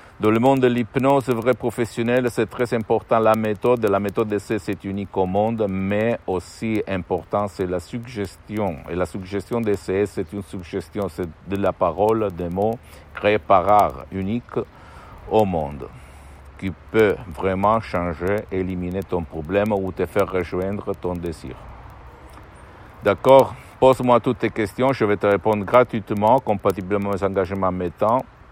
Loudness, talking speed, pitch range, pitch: -21 LUFS, 150 wpm, 95-110 Hz, 100 Hz